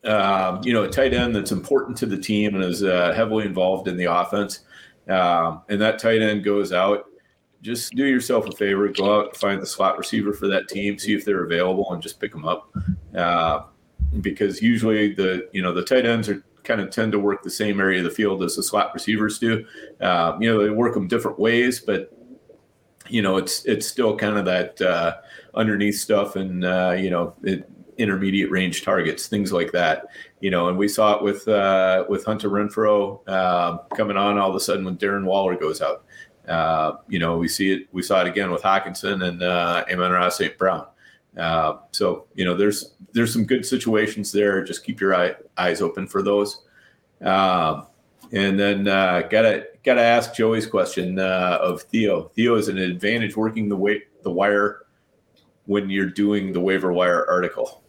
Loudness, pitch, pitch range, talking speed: -21 LUFS, 100 Hz, 95-105 Hz, 200 wpm